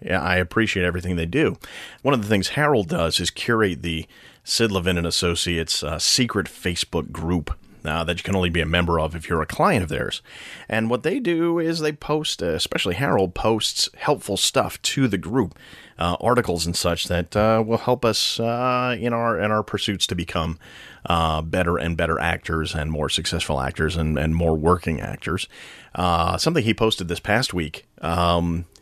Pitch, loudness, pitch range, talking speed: 90 Hz, -22 LUFS, 85-110 Hz, 195 wpm